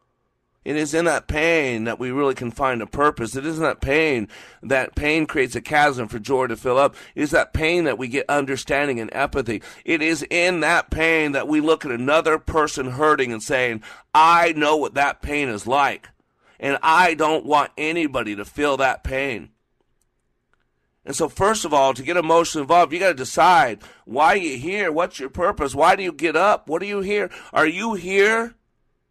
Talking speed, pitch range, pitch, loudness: 205 wpm, 130-160 Hz, 145 Hz, -20 LUFS